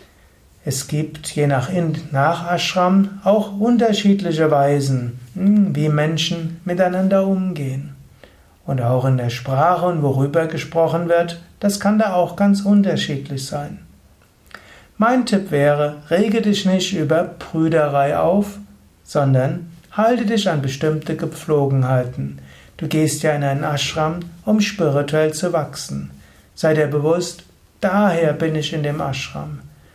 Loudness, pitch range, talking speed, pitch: -18 LUFS, 140-185 Hz, 130 wpm, 160 Hz